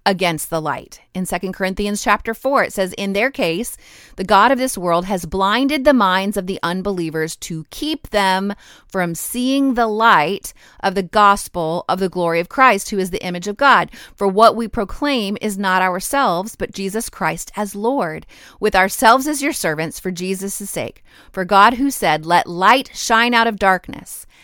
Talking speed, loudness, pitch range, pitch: 185 wpm, -17 LUFS, 185-230 Hz, 200 Hz